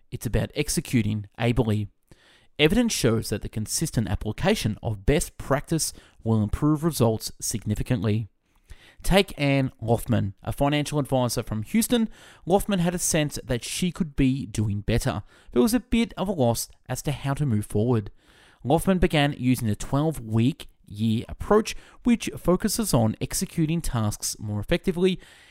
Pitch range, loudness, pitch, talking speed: 110-165 Hz, -25 LUFS, 130 Hz, 145 wpm